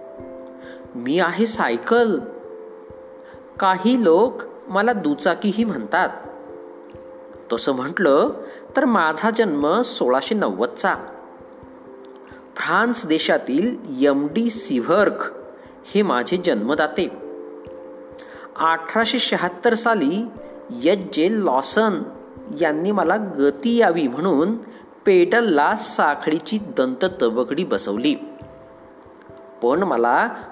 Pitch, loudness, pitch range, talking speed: 220 Hz, -20 LUFS, 155-245 Hz, 80 wpm